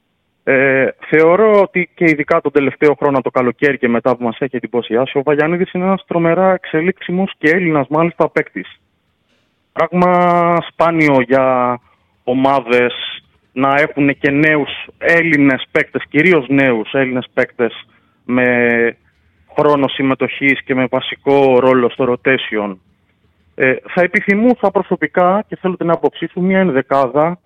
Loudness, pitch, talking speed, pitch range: -14 LUFS, 140 Hz, 130 wpm, 125-170 Hz